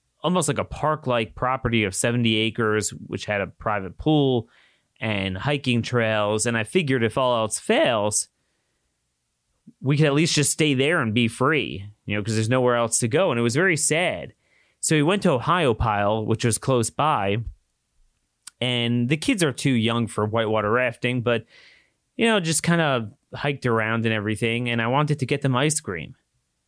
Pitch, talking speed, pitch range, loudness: 120 Hz, 190 wpm, 110-140 Hz, -22 LUFS